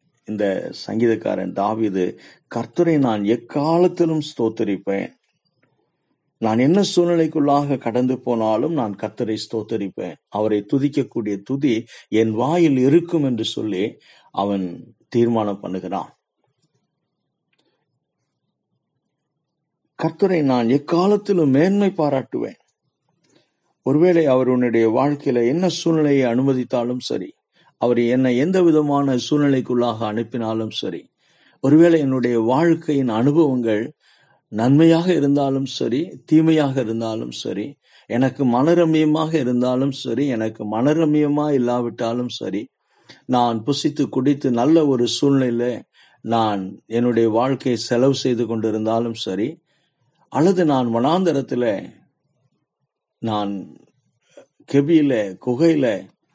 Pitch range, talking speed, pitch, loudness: 115-150 Hz, 90 wpm, 130 Hz, -19 LUFS